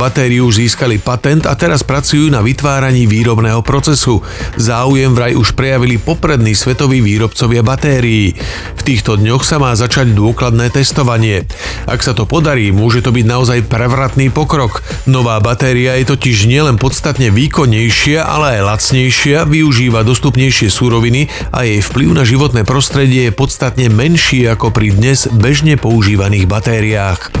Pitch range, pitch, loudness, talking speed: 115-135 Hz, 125 Hz, -10 LUFS, 140 wpm